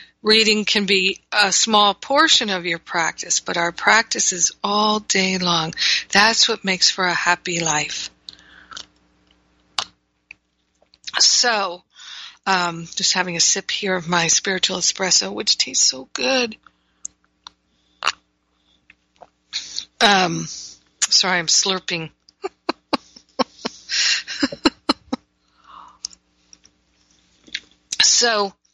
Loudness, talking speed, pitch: -17 LUFS, 90 wpm, 170 Hz